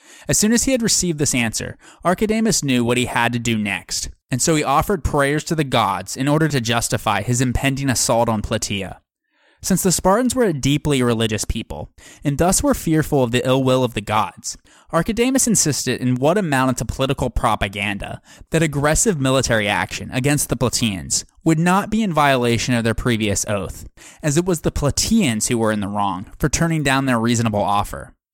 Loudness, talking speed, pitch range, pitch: -19 LUFS, 195 wpm, 115-160 Hz, 130 Hz